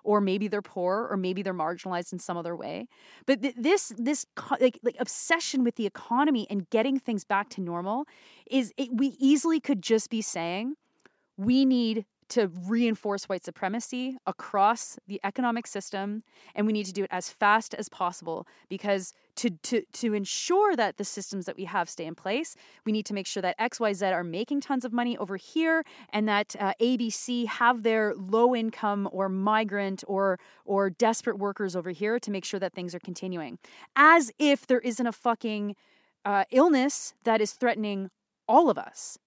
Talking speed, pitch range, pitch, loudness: 195 wpm, 195-245 Hz, 215 Hz, -28 LUFS